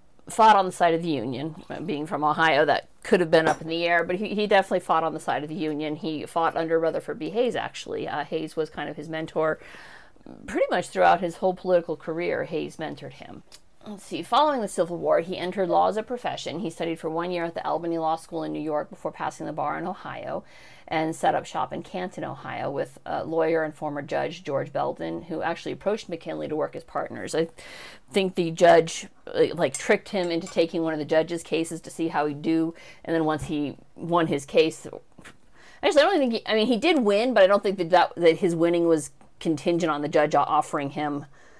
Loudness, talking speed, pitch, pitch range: -25 LUFS, 230 wpm, 165 Hz, 155-180 Hz